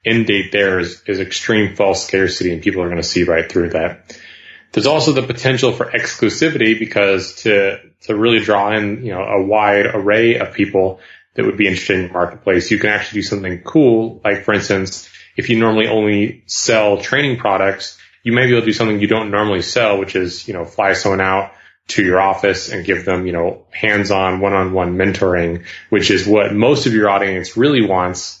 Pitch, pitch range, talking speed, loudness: 100 Hz, 95-110 Hz, 210 wpm, -15 LUFS